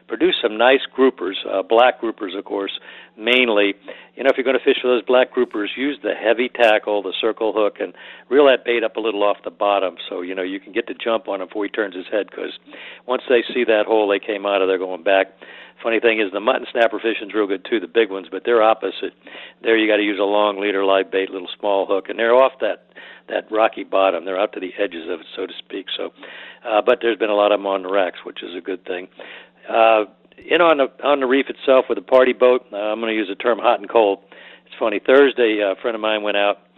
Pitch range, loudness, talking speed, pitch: 100-125 Hz, -19 LUFS, 260 wpm, 110 Hz